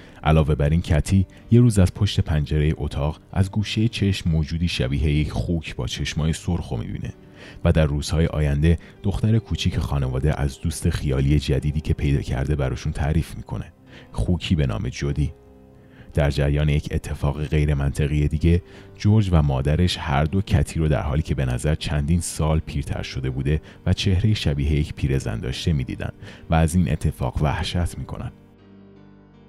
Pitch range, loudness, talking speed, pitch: 75-95 Hz, -23 LUFS, 155 wpm, 80 Hz